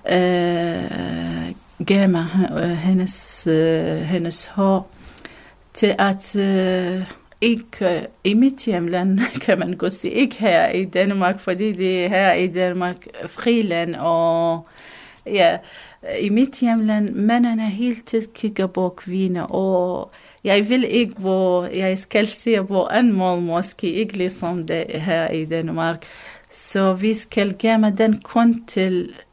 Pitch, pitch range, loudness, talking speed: 190 Hz, 180-215 Hz, -20 LUFS, 130 wpm